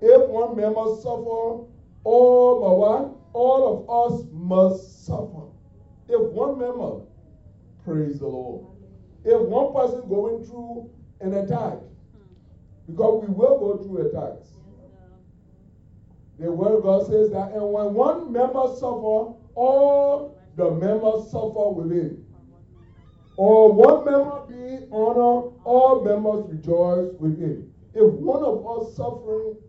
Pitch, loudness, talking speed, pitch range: 220 Hz, -21 LUFS, 125 wpm, 170-245 Hz